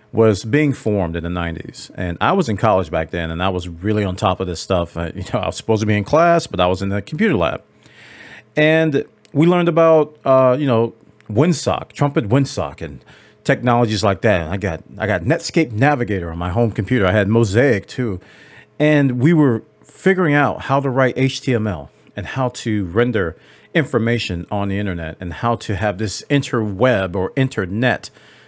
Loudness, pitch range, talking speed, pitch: -18 LUFS, 95-135 Hz, 195 wpm, 110 Hz